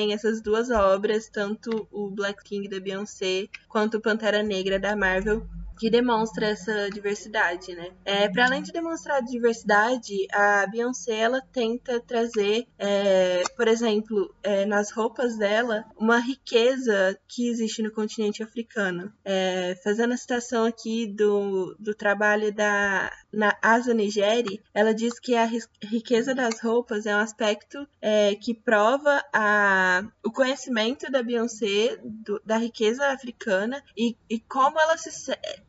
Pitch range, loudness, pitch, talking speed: 205-235 Hz, -25 LUFS, 215 Hz, 145 wpm